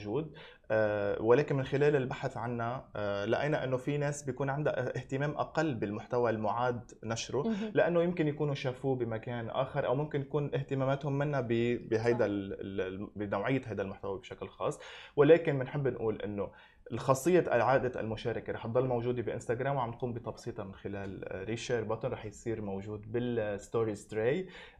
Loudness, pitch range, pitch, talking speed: -33 LUFS, 110-140 Hz, 120 Hz, 140 wpm